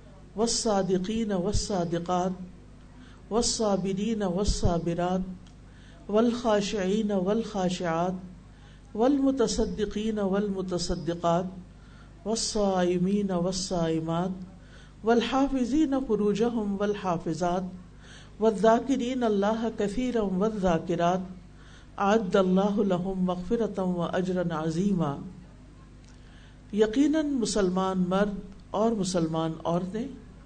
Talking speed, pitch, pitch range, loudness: 80 wpm, 195 Hz, 180-220 Hz, -27 LUFS